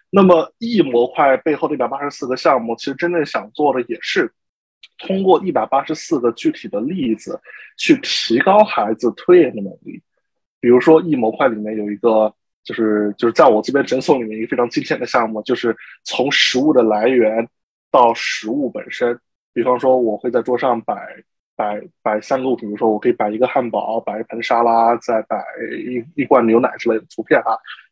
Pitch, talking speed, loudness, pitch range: 125 Hz, 275 characters per minute, -17 LUFS, 110-170 Hz